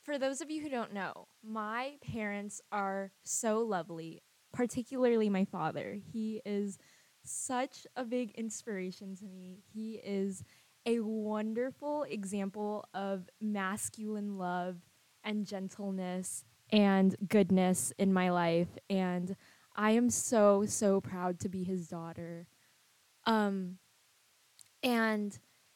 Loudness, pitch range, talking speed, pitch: -34 LUFS, 185-220 Hz, 115 wpm, 205 Hz